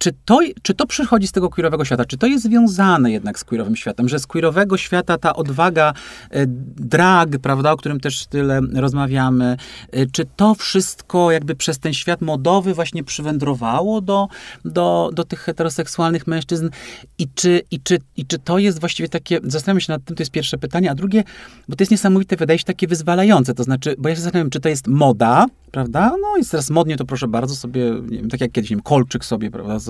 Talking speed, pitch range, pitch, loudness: 210 wpm, 130-180 Hz, 160 Hz, -18 LUFS